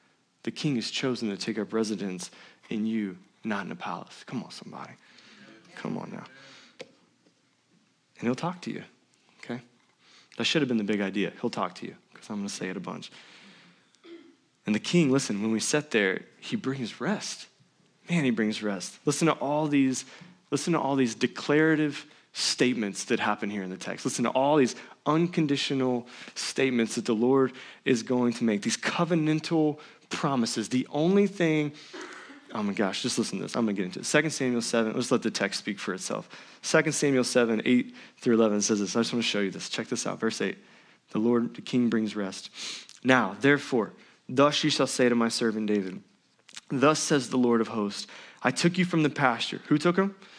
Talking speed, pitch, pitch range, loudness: 200 wpm, 125 Hz, 115-150 Hz, -27 LUFS